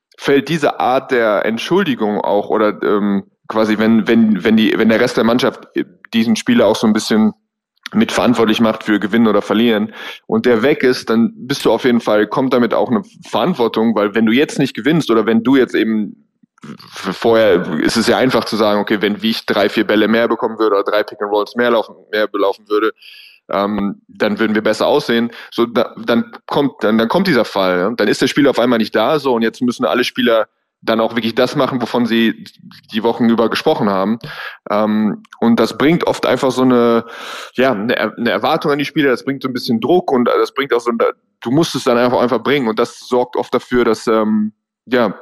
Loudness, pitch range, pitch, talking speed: -15 LUFS, 110-140 Hz, 115 Hz, 220 wpm